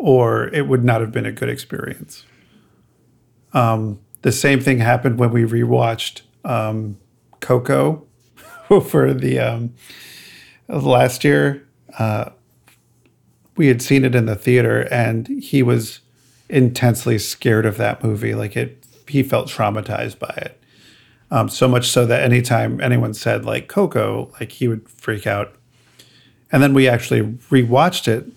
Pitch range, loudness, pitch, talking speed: 115-130 Hz, -17 LUFS, 120 Hz, 145 wpm